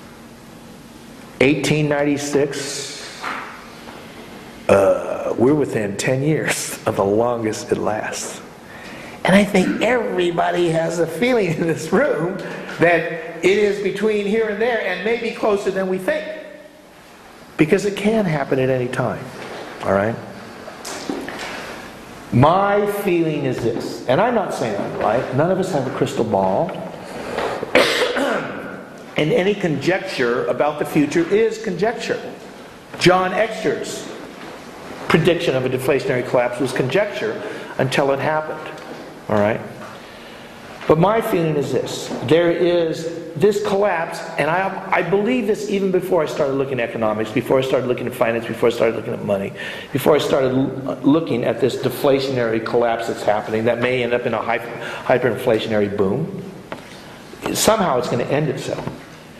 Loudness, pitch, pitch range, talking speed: -19 LUFS, 165 Hz, 130-200 Hz, 140 wpm